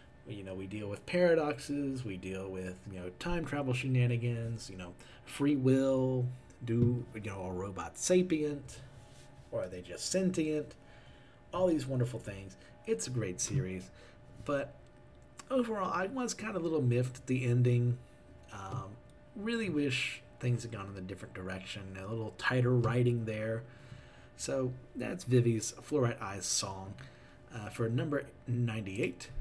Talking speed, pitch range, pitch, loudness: 150 wpm, 105-140 Hz, 120 Hz, -34 LUFS